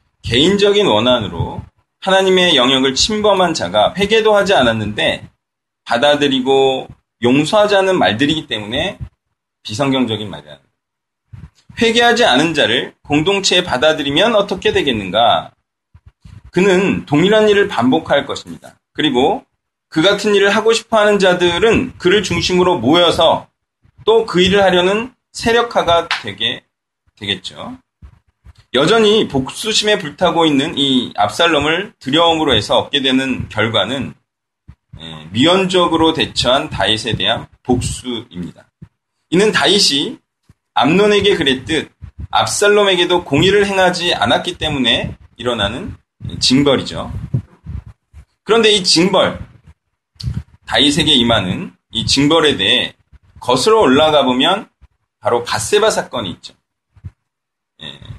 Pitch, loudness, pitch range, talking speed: 170 Hz, -13 LUFS, 130-205 Hz, 265 characters per minute